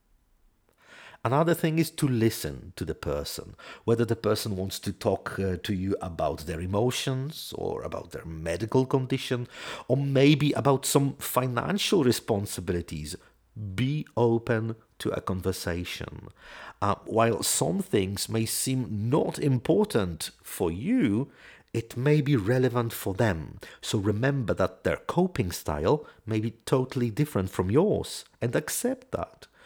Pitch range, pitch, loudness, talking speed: 100-140 Hz, 120 Hz, -28 LUFS, 135 wpm